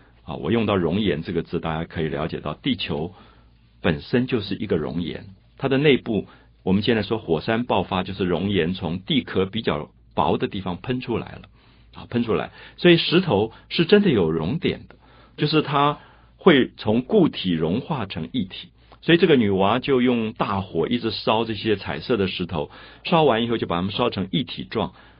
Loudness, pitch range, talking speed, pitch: -22 LUFS, 85-125 Hz, 275 characters per minute, 100 Hz